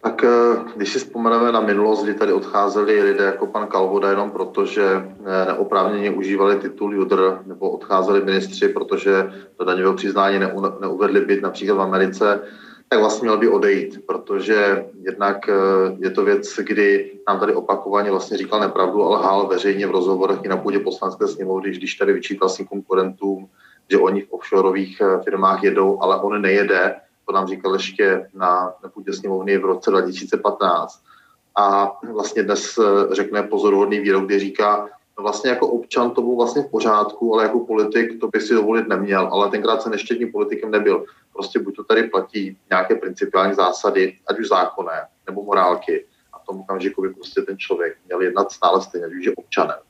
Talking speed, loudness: 170 wpm, -19 LUFS